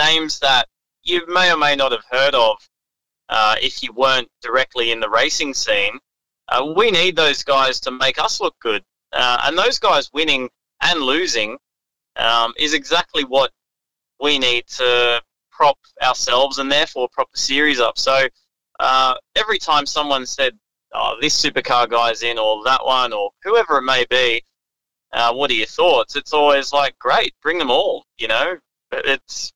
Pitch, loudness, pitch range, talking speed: 135 Hz, -17 LUFS, 125-150 Hz, 175 wpm